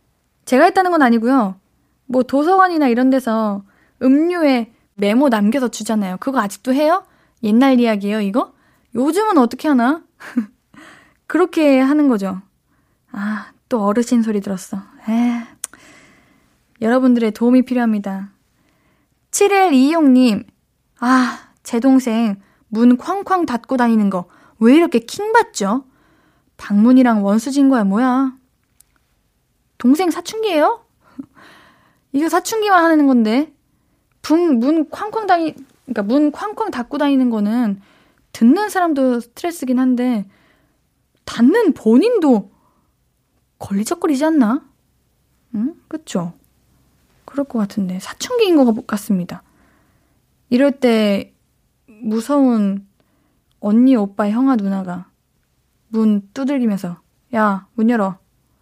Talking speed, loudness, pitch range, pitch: 230 characters per minute, -16 LUFS, 220-290 Hz, 250 Hz